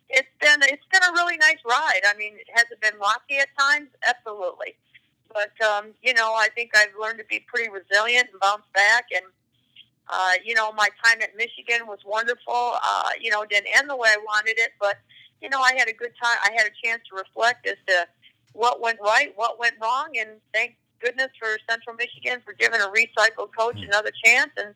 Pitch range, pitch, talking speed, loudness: 210-240 Hz, 225 Hz, 215 wpm, -21 LUFS